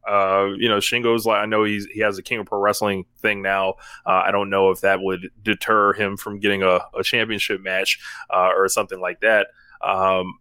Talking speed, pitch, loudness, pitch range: 220 wpm, 100 Hz, -20 LUFS, 95-105 Hz